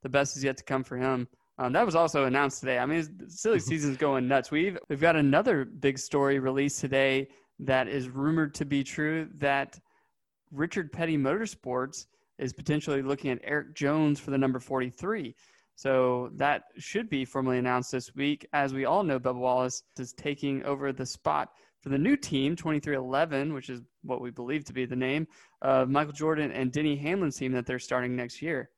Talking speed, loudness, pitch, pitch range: 195 wpm, -29 LUFS, 140 Hz, 130-150 Hz